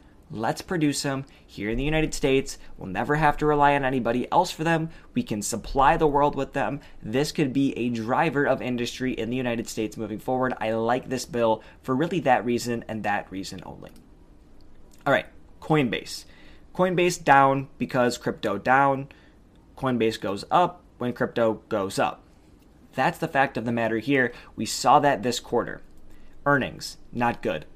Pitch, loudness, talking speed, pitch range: 125 Hz, -25 LUFS, 175 wpm, 115-140 Hz